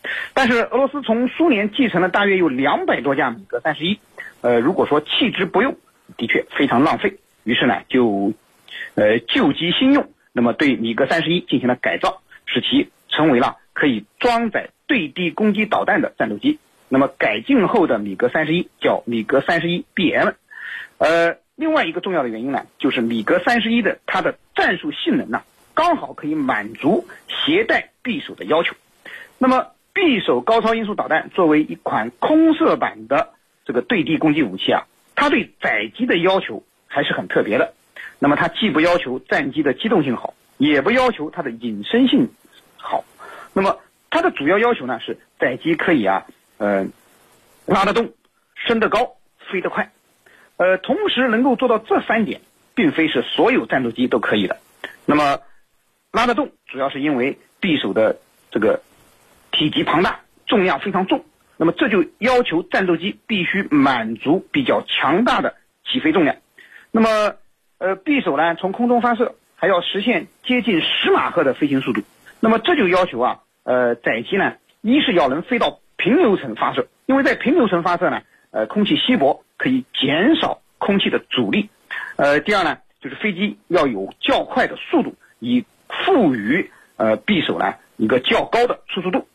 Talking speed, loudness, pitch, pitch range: 265 characters per minute, -19 LUFS, 230 Hz, 175-280 Hz